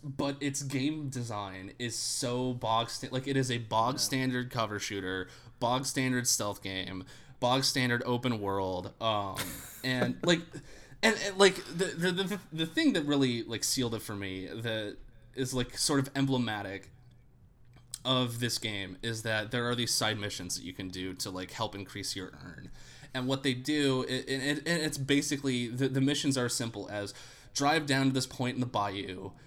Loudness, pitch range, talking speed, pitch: -31 LUFS, 105-135 Hz, 185 wpm, 125 Hz